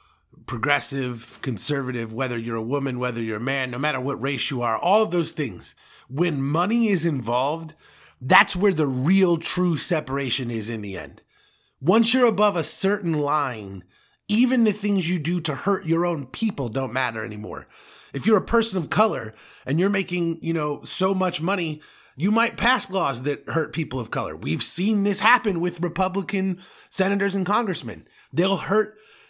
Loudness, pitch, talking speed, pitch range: -23 LUFS, 165 Hz, 180 wpm, 130-195 Hz